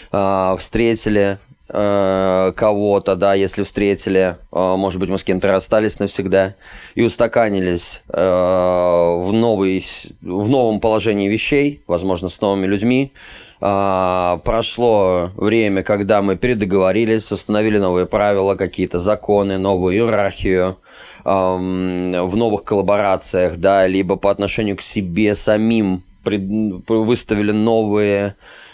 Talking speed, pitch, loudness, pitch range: 100 wpm, 100 Hz, -17 LUFS, 95-110 Hz